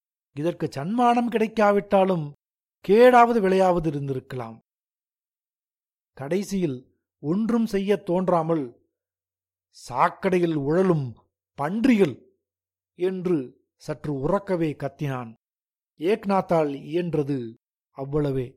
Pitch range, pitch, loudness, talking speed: 135-190 Hz, 165 Hz, -23 LUFS, 65 wpm